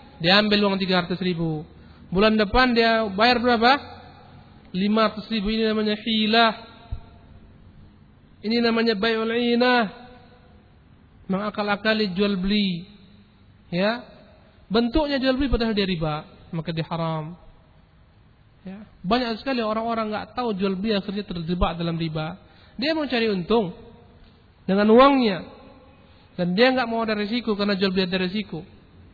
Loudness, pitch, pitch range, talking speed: -22 LUFS, 210 Hz, 180-230 Hz, 130 wpm